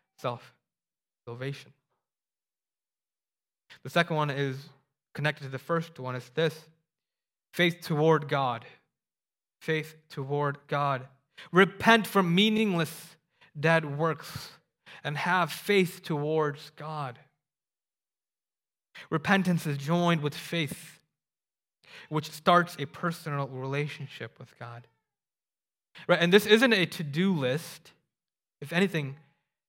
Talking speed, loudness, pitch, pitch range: 100 wpm, -28 LUFS, 155 Hz, 140-170 Hz